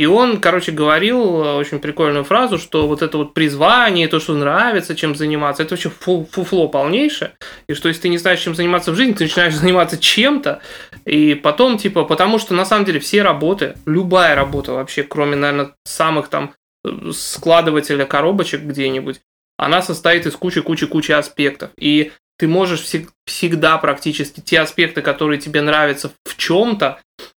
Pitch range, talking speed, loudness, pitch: 150-180 Hz, 160 wpm, -15 LUFS, 160 Hz